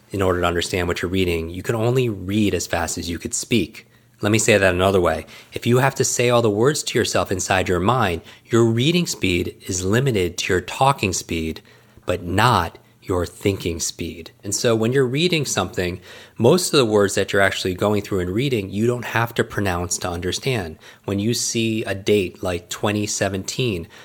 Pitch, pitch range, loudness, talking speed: 100 Hz, 90-115 Hz, -20 LUFS, 200 wpm